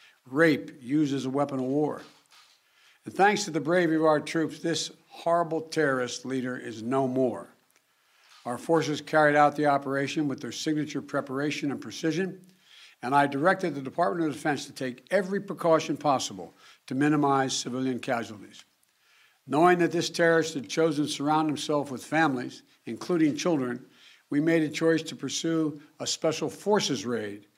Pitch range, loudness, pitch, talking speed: 135-165 Hz, -27 LUFS, 150 Hz, 160 wpm